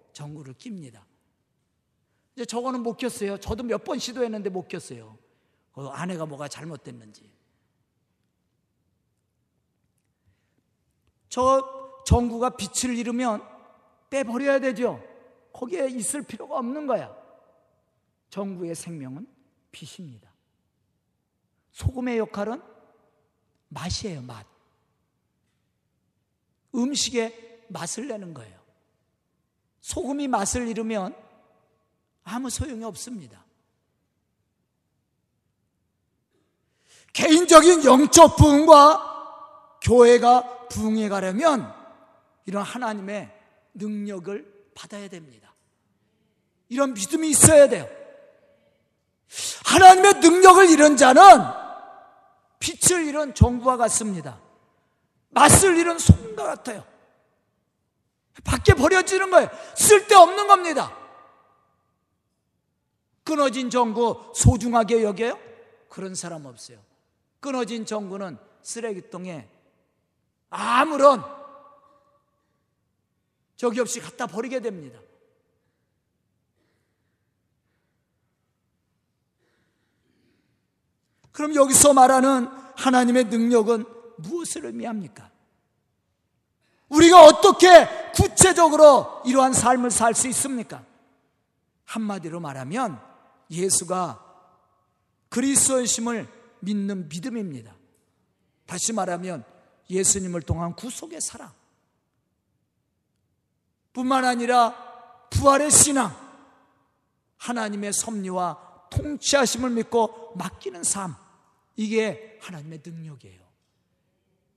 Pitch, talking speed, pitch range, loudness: 235 Hz, 195 characters per minute, 185-280 Hz, -18 LUFS